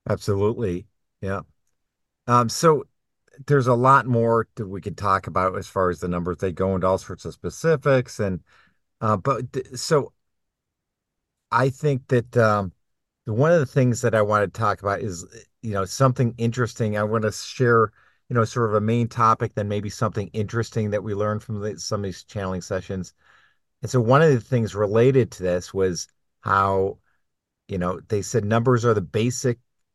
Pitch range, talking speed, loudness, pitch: 95-120 Hz, 190 wpm, -22 LUFS, 110 Hz